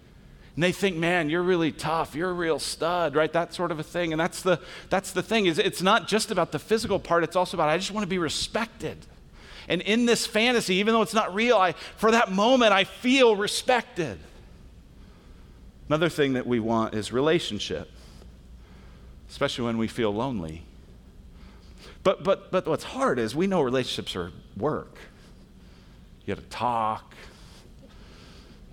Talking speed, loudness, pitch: 175 wpm, -25 LUFS, 160 Hz